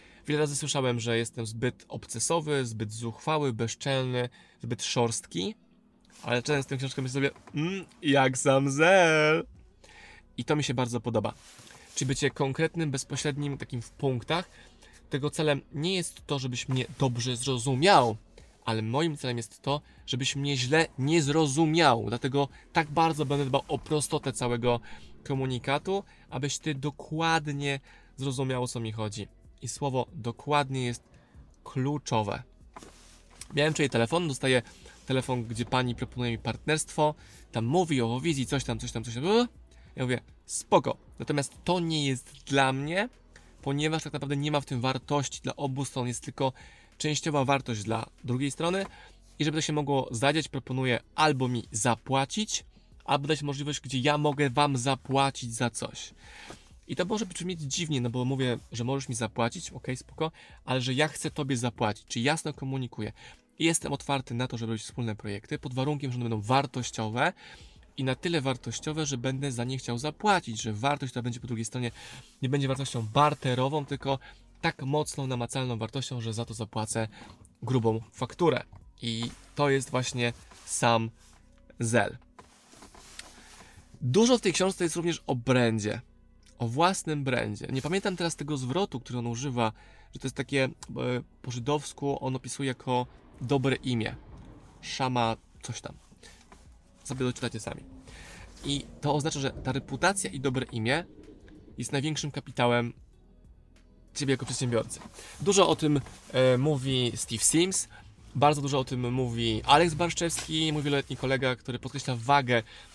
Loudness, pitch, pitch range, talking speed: -29 LUFS, 135 Hz, 120-150 Hz, 155 wpm